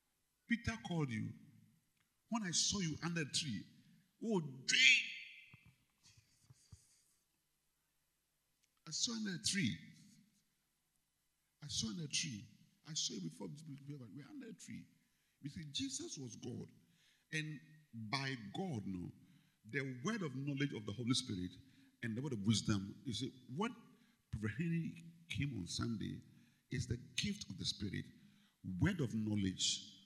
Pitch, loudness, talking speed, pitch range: 145 Hz, -40 LUFS, 140 wpm, 120-185 Hz